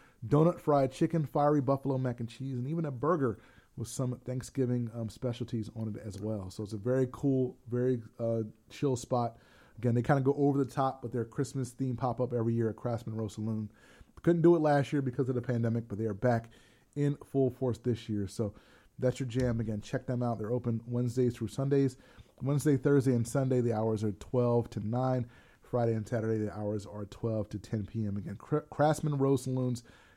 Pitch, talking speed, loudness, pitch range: 125 Hz, 210 wpm, -32 LUFS, 115-135 Hz